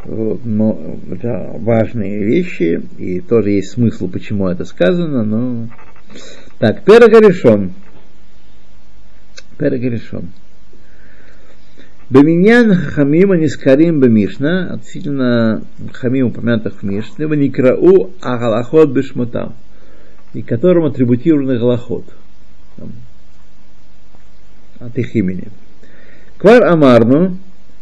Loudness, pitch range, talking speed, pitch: -13 LUFS, 105-150 Hz, 80 wpm, 120 Hz